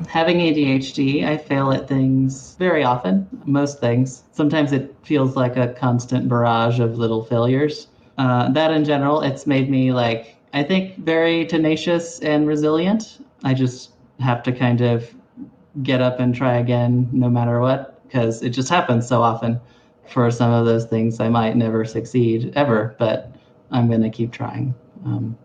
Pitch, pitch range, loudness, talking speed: 125 Hz, 120-145 Hz, -19 LUFS, 165 wpm